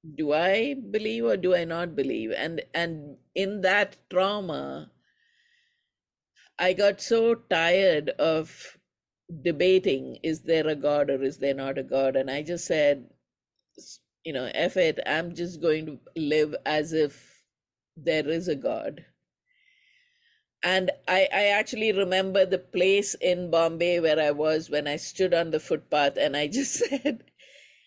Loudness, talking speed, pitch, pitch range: -26 LUFS, 150 wpm, 175 Hz, 155-210 Hz